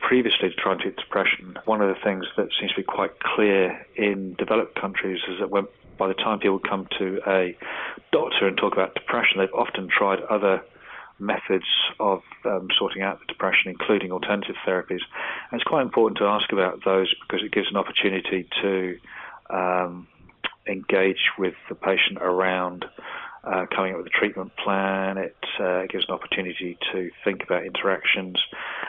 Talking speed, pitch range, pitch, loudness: 175 wpm, 90-100 Hz, 95 Hz, -24 LUFS